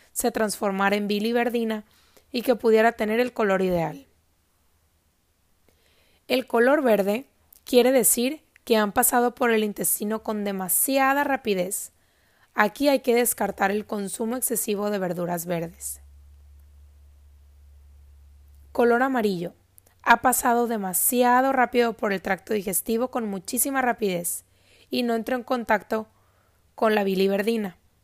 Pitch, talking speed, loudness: 210 Hz, 120 wpm, -23 LUFS